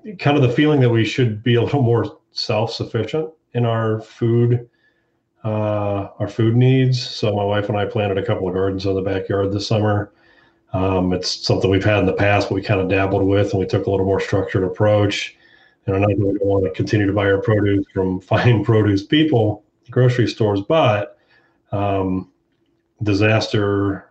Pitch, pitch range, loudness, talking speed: 105 Hz, 100-120 Hz, -18 LUFS, 190 wpm